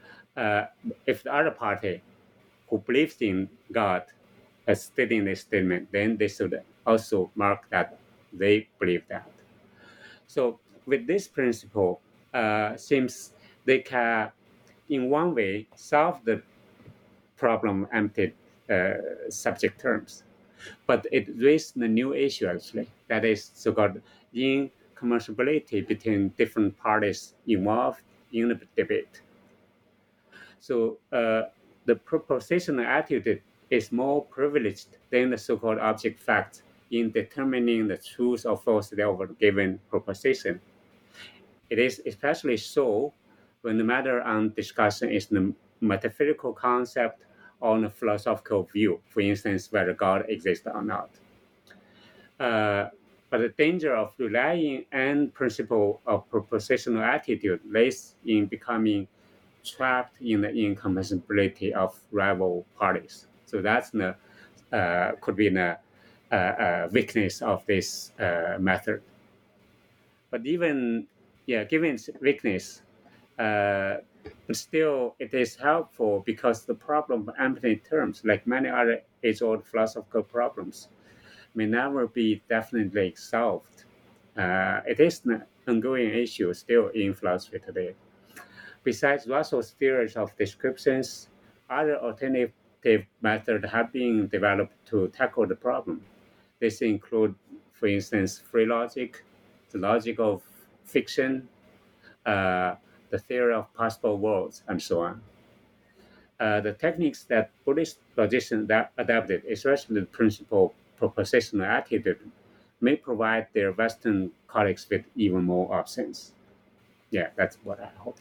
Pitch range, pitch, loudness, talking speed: 105-130 Hz, 115 Hz, -27 LUFS, 120 wpm